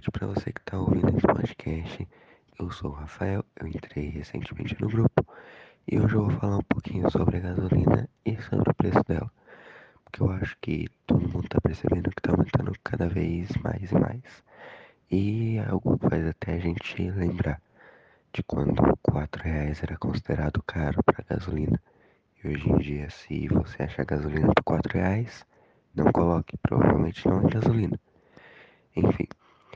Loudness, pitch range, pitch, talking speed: -27 LUFS, 80-110 Hz, 95 Hz, 165 wpm